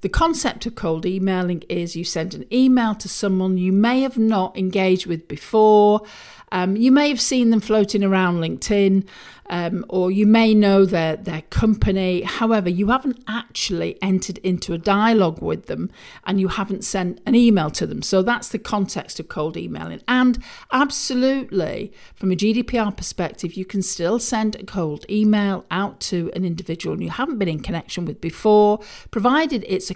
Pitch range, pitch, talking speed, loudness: 185-225 Hz, 200 Hz, 175 wpm, -20 LUFS